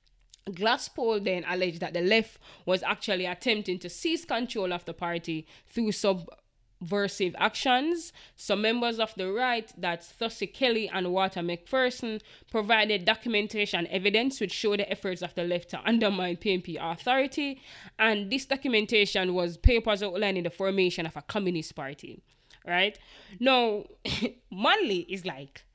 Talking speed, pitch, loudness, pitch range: 140 wpm, 200 Hz, -28 LUFS, 175-225 Hz